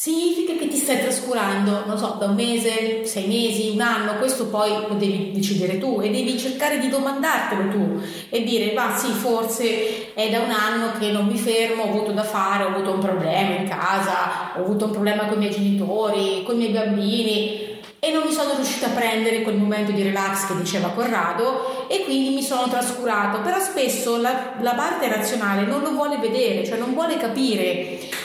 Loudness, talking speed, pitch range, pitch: -22 LUFS, 200 wpm, 205-245 Hz, 225 Hz